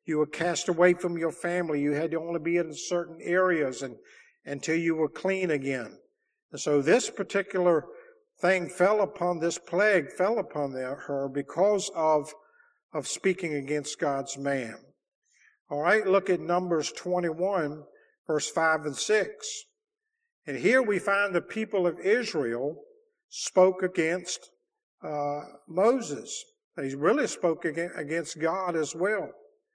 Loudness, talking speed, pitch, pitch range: -28 LUFS, 140 wpm, 175 Hz, 150-195 Hz